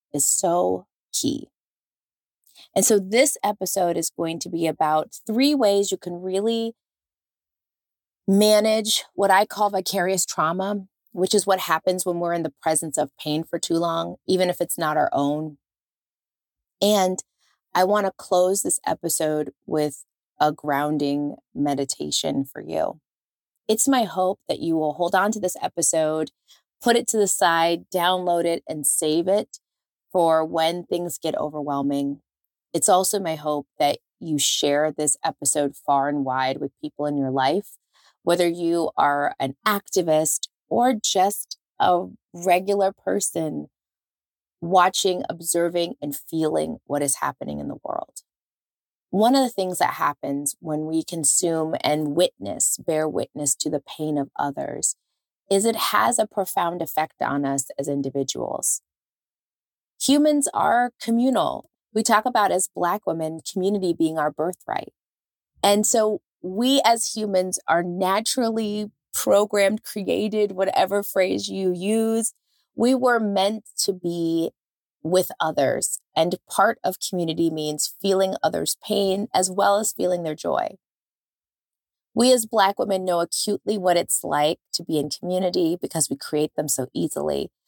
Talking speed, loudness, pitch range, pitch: 145 wpm, -22 LUFS, 155-200 Hz, 175 Hz